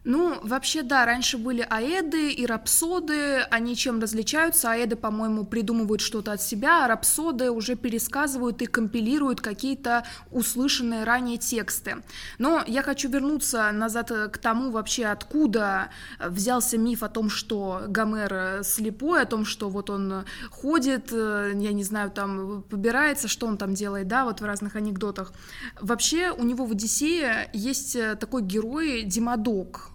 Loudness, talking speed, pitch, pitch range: -25 LUFS, 145 wpm, 230 Hz, 215-260 Hz